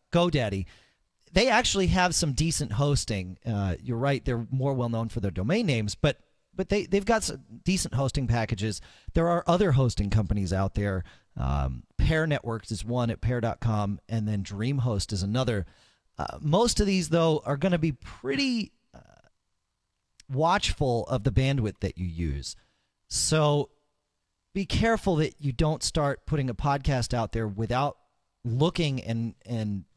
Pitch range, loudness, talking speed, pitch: 105-150 Hz, -27 LUFS, 160 wpm, 125 Hz